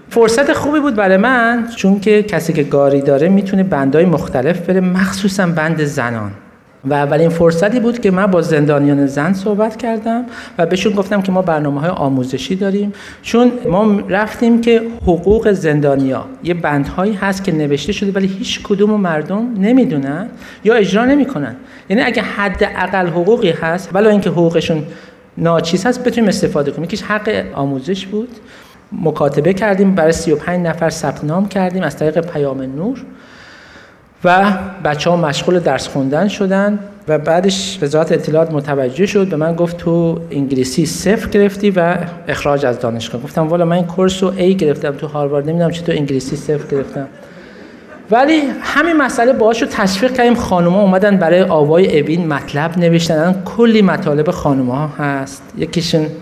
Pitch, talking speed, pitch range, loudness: 180 Hz, 160 wpm, 155-210 Hz, -14 LUFS